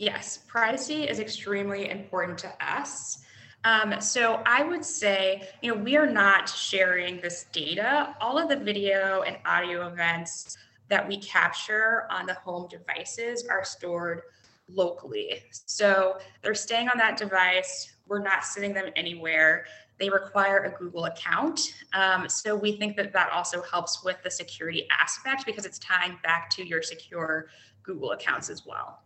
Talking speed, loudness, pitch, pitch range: 155 wpm, -26 LUFS, 190 Hz, 175-215 Hz